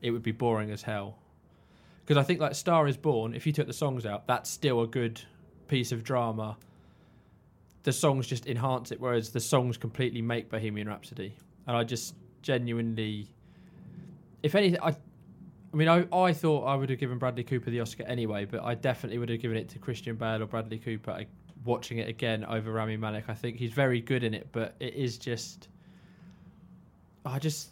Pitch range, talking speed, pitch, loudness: 115-140 Hz, 195 wpm, 120 Hz, -31 LUFS